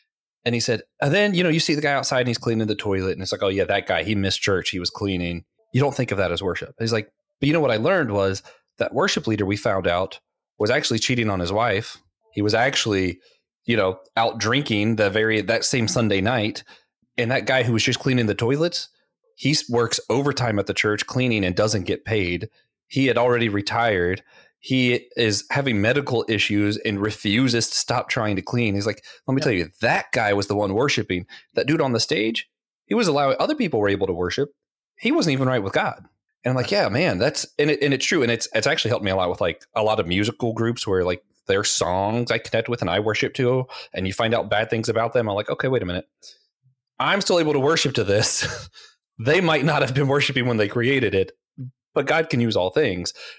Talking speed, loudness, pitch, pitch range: 240 wpm, -21 LUFS, 115 Hz, 105-130 Hz